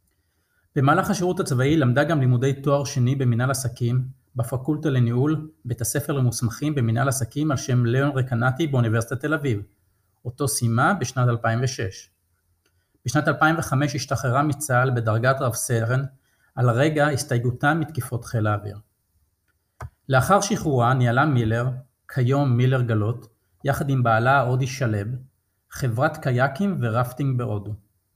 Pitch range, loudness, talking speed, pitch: 115-140 Hz, -22 LUFS, 120 wpm, 125 Hz